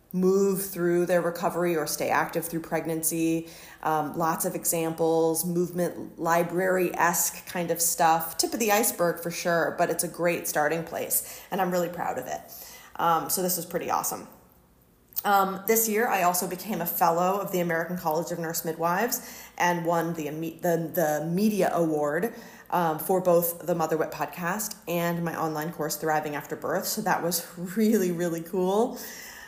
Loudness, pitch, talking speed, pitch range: -26 LUFS, 170 Hz, 175 wpm, 165-185 Hz